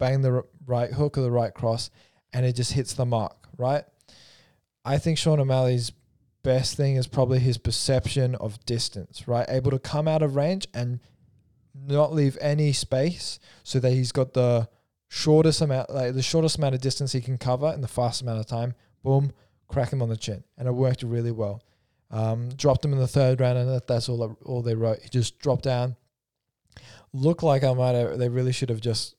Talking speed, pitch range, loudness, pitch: 205 wpm, 120-135 Hz, -25 LUFS, 125 Hz